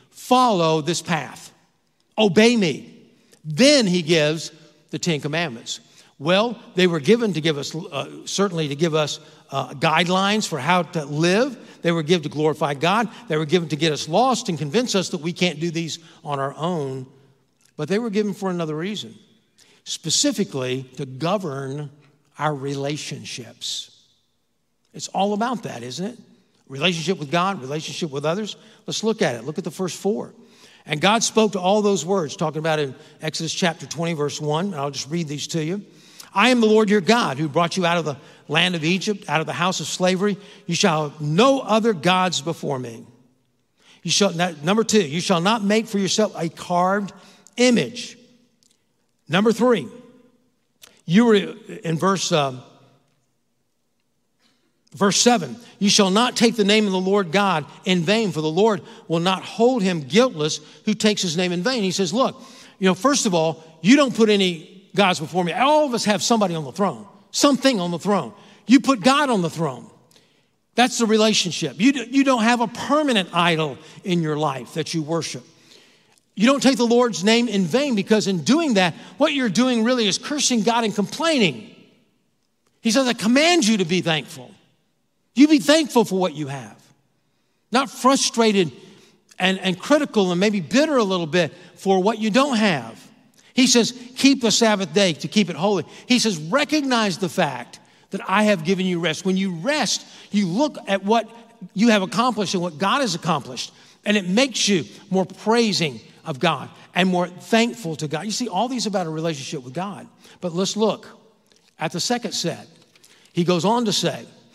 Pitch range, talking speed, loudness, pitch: 160-225 Hz, 190 wpm, -20 LUFS, 190 Hz